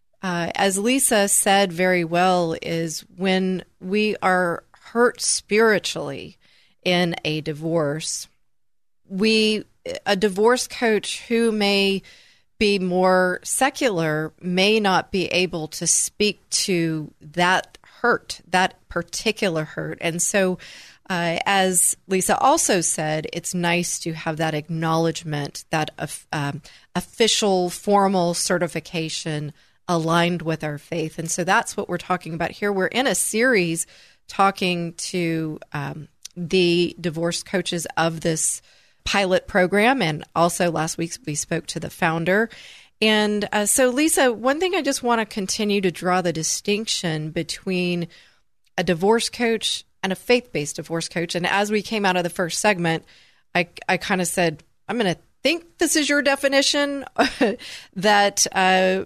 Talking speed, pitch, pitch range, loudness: 140 wpm, 185 Hz, 170-210 Hz, -21 LUFS